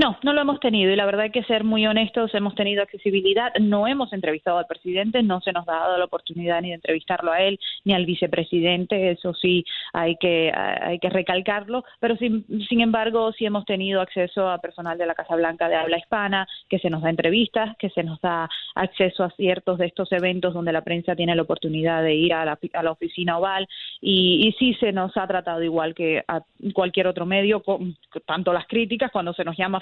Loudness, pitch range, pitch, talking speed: -22 LUFS, 170-205 Hz, 185 Hz, 225 wpm